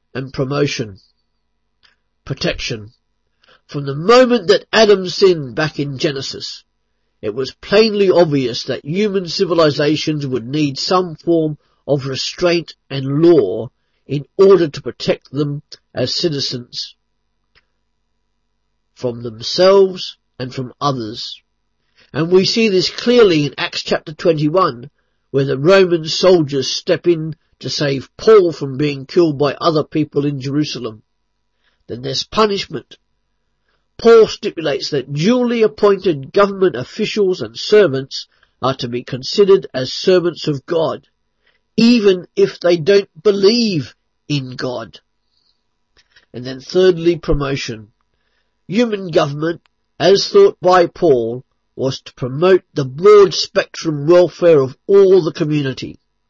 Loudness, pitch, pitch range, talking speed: -15 LUFS, 155 Hz, 135-190 Hz, 120 wpm